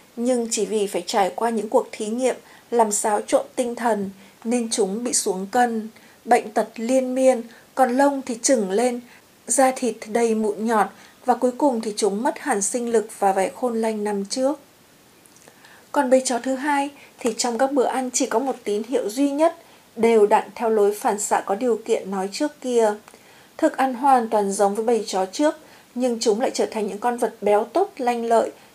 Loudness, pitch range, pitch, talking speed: -22 LUFS, 215-260 Hz, 235 Hz, 205 wpm